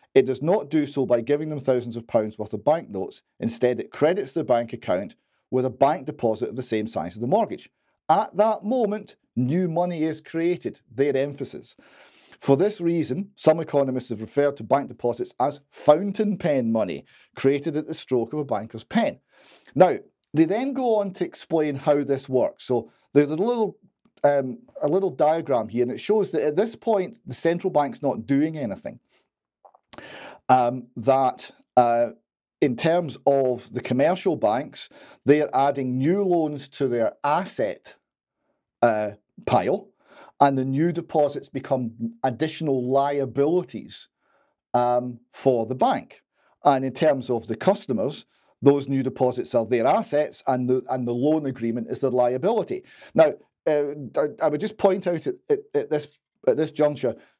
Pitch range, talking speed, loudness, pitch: 130-165 Hz, 165 wpm, -24 LUFS, 145 Hz